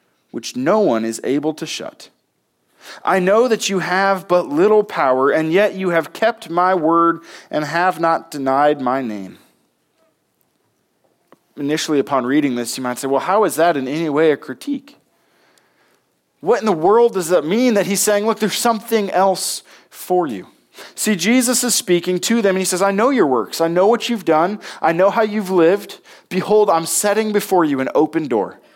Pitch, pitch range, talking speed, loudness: 185 Hz, 155-215 Hz, 190 wpm, -17 LUFS